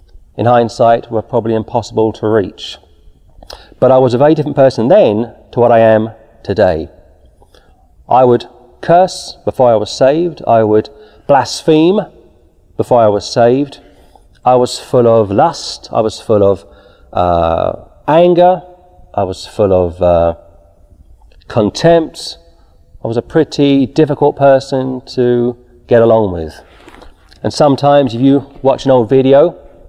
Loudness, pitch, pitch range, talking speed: -12 LUFS, 115 Hz, 95-135 Hz, 140 wpm